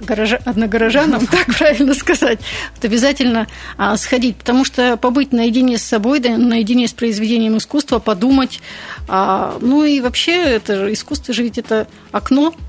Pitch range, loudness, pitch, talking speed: 225-270 Hz, -15 LUFS, 245 Hz, 145 wpm